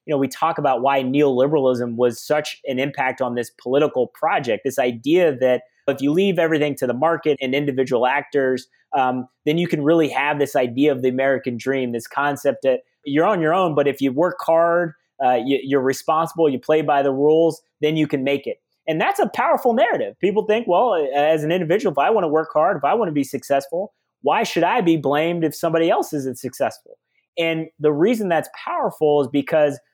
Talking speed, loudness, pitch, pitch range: 210 wpm, -20 LUFS, 150 Hz, 135-165 Hz